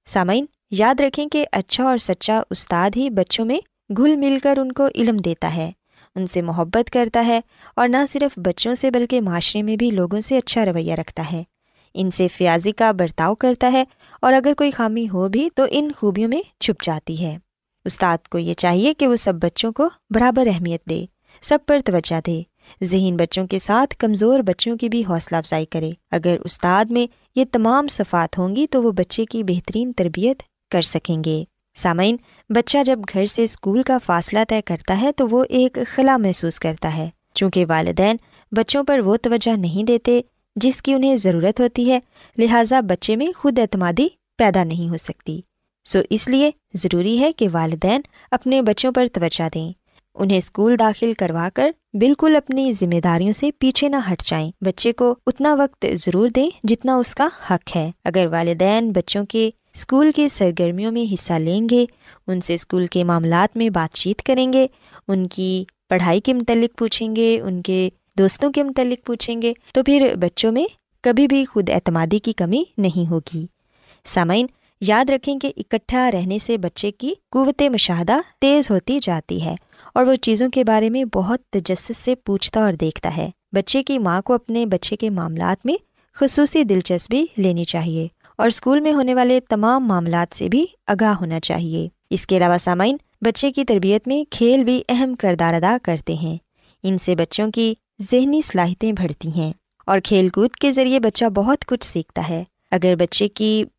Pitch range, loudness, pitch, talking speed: 180-255 Hz, -19 LUFS, 220 Hz, 185 wpm